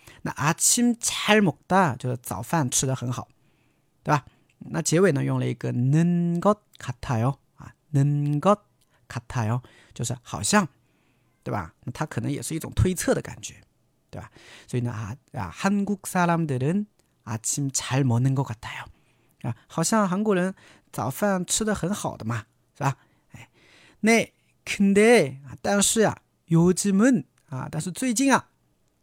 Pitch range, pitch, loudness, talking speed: 125-185 Hz, 140 Hz, -24 LUFS, 215 characters per minute